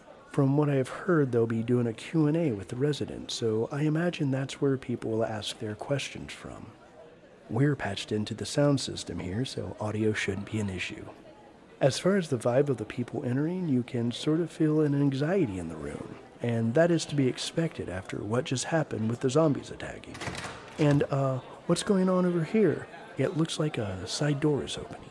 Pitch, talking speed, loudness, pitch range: 135 Hz, 205 wpm, -29 LUFS, 115-155 Hz